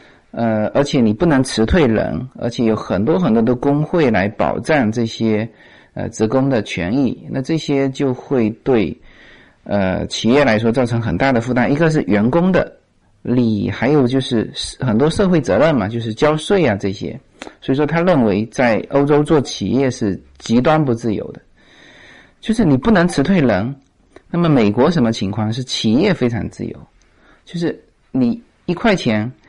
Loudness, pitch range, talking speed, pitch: -16 LUFS, 110-150 Hz, 245 characters per minute, 125 Hz